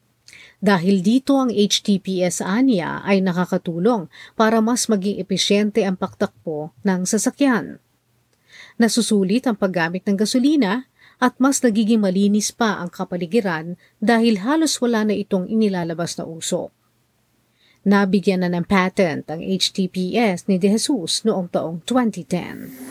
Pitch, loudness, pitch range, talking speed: 200 Hz, -19 LUFS, 180-225 Hz, 125 wpm